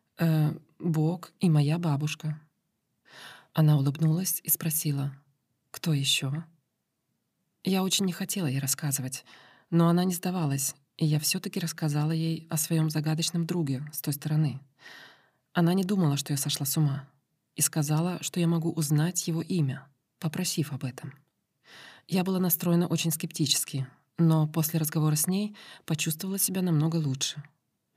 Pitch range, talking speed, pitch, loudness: 145-170 Hz, 140 wpm, 160 Hz, -28 LUFS